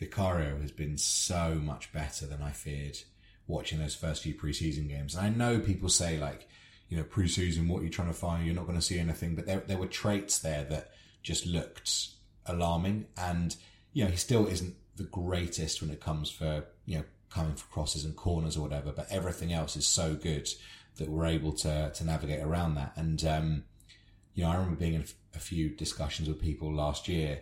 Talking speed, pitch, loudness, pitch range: 210 wpm, 85 Hz, -33 LUFS, 75-95 Hz